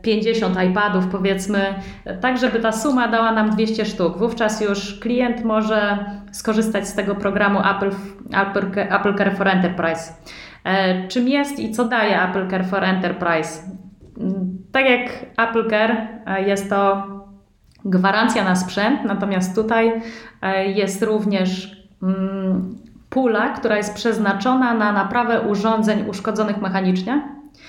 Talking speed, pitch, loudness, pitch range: 120 wpm, 205 Hz, -19 LUFS, 195-225 Hz